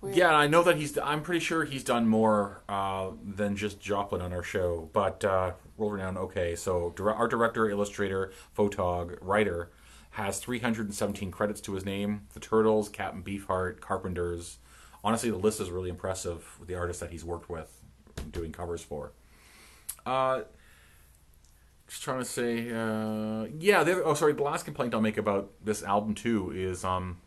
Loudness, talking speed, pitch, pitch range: -30 LUFS, 165 wpm, 100 Hz, 90-110 Hz